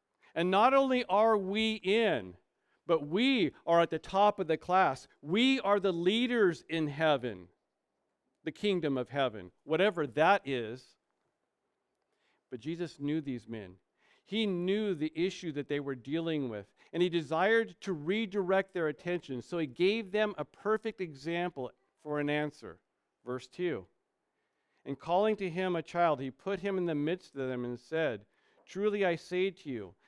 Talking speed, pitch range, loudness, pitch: 165 wpm, 145-195 Hz, -32 LUFS, 170 Hz